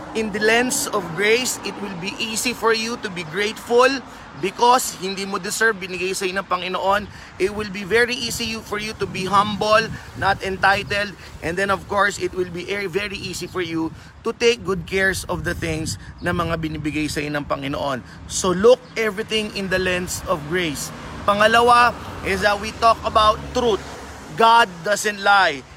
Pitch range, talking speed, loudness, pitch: 185-225 Hz, 180 wpm, -20 LUFS, 200 Hz